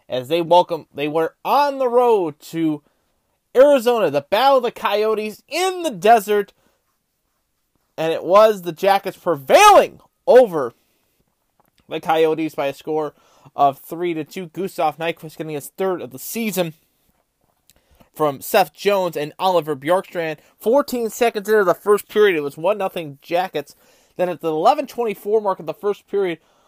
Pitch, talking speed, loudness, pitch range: 180 Hz, 155 wpm, -18 LUFS, 160-210 Hz